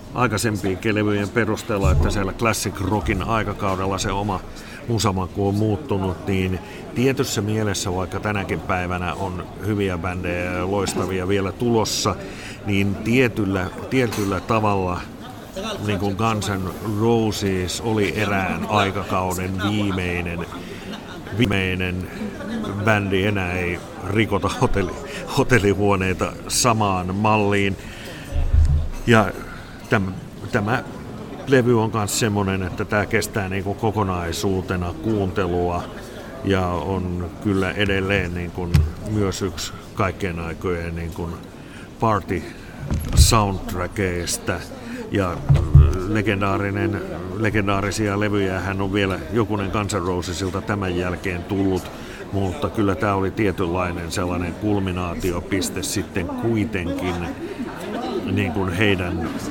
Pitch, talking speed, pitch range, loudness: 100 Hz, 90 wpm, 90-105 Hz, -22 LUFS